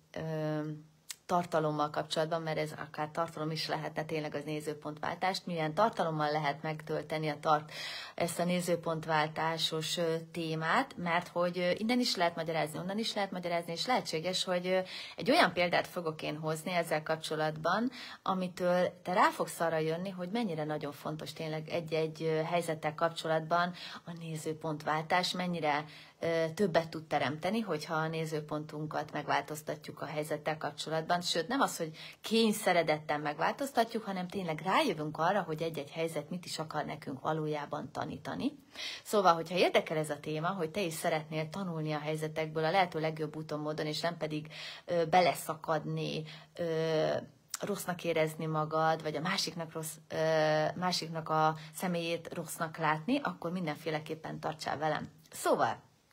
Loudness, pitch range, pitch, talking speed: -34 LUFS, 155-175 Hz, 160 Hz, 140 wpm